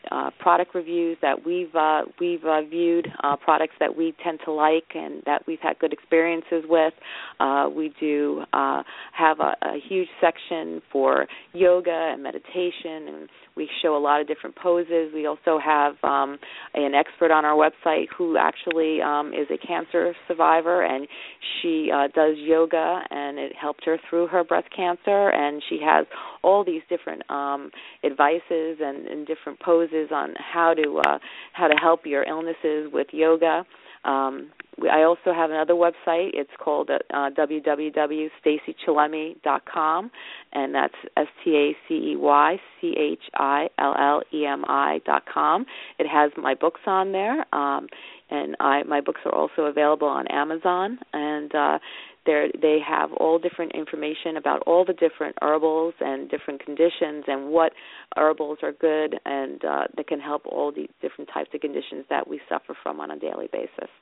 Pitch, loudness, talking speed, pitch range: 160 Hz, -23 LUFS, 155 wpm, 150-170 Hz